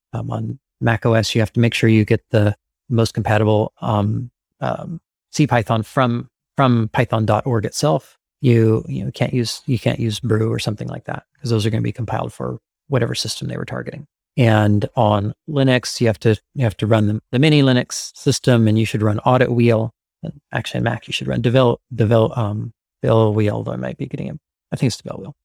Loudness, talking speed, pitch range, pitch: -19 LUFS, 210 wpm, 110-125 Hz, 115 Hz